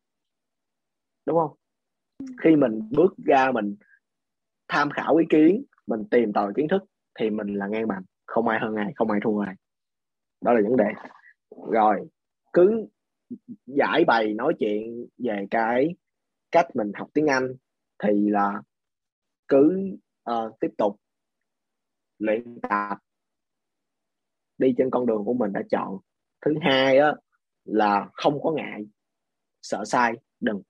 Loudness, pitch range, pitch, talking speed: -24 LUFS, 105-155 Hz, 115 Hz, 140 wpm